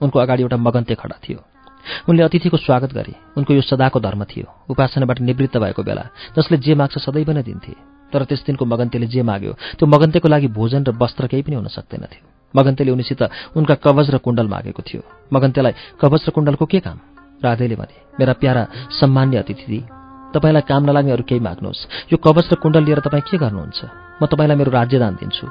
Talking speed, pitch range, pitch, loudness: 190 wpm, 120-150 Hz, 135 Hz, -17 LUFS